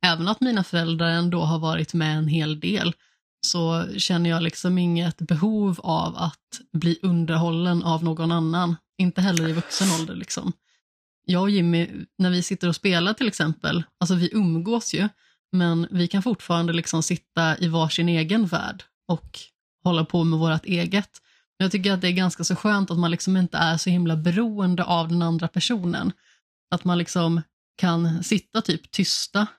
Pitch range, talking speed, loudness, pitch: 165-190 Hz, 175 wpm, -23 LUFS, 175 Hz